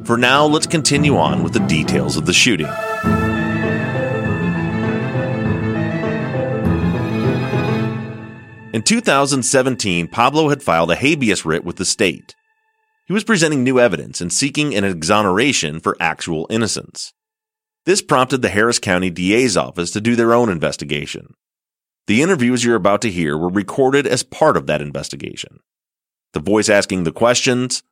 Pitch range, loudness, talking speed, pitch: 105-140 Hz, -16 LUFS, 140 wpm, 115 Hz